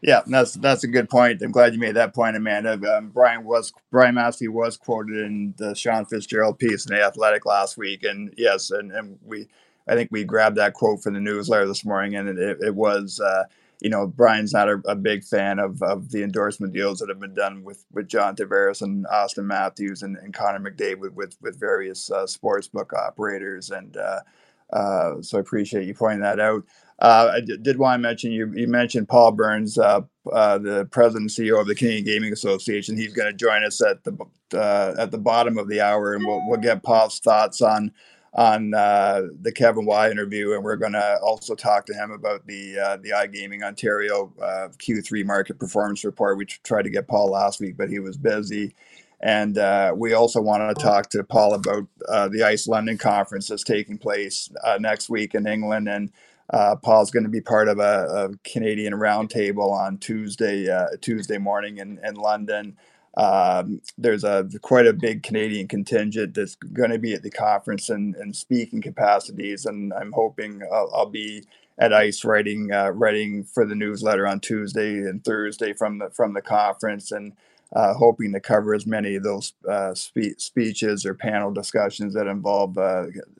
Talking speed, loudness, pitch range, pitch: 200 wpm, -22 LUFS, 100-115 Hz, 105 Hz